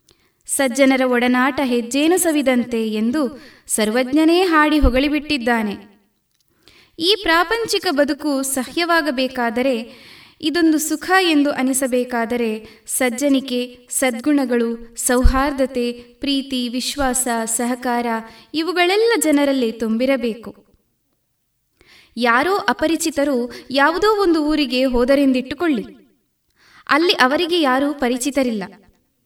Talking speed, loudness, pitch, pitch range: 70 wpm, -18 LUFS, 265 Hz, 245-300 Hz